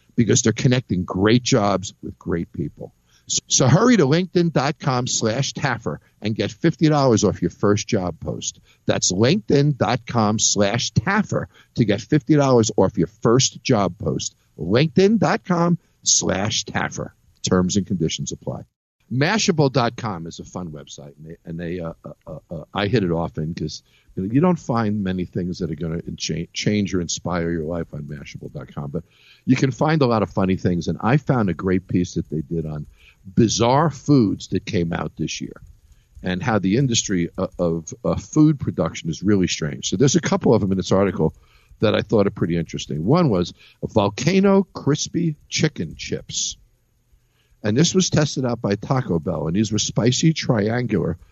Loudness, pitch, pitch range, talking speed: -20 LUFS, 110 Hz, 90-140 Hz, 175 wpm